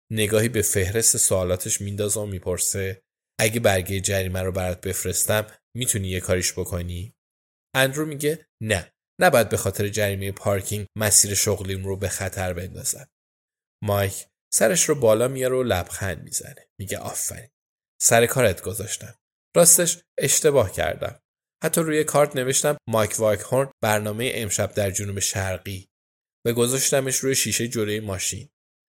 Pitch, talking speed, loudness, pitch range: 105 Hz, 135 wpm, -22 LUFS, 95-120 Hz